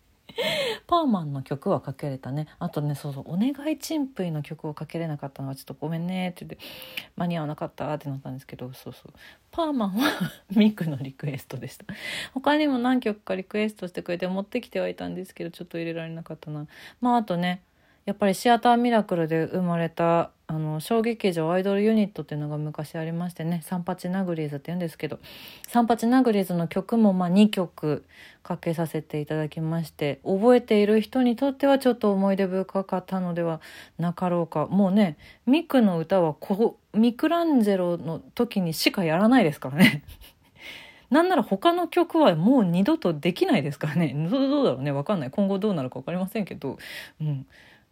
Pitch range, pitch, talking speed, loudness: 155-220 Hz, 180 Hz, 420 characters per minute, -25 LUFS